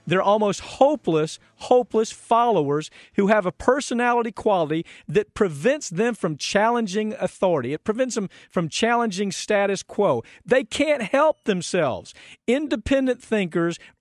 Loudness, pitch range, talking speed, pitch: -22 LUFS, 185-245 Hz, 125 wpm, 215 Hz